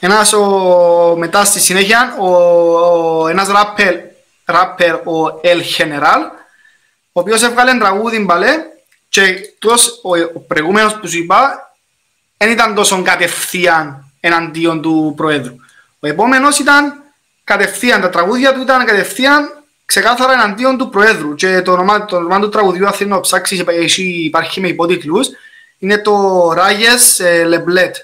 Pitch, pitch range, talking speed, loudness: 190 Hz, 170-225 Hz, 135 wpm, -11 LUFS